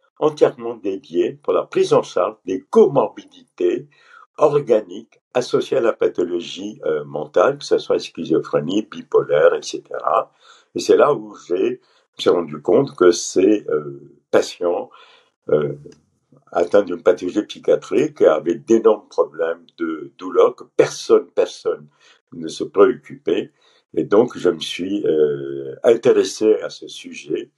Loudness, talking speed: -19 LUFS, 130 wpm